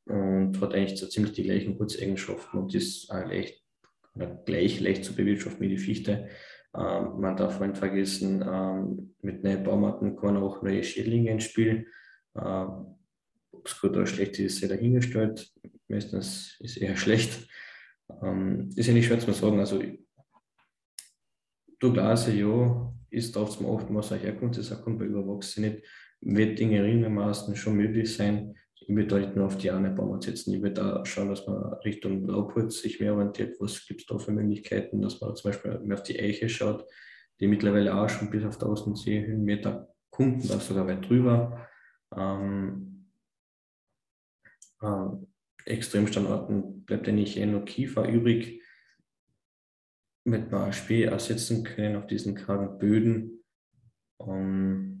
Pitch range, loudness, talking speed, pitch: 100-115 Hz, -29 LUFS, 155 wpm, 105 Hz